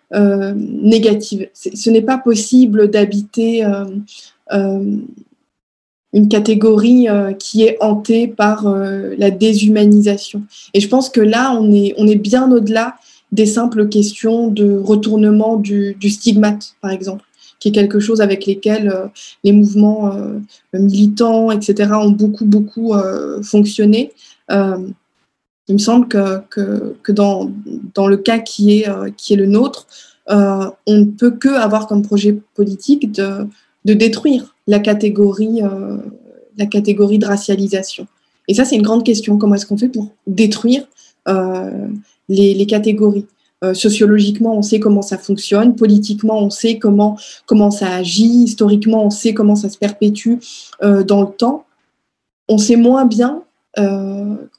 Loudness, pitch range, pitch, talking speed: -13 LUFS, 205-225 Hz, 210 Hz, 155 wpm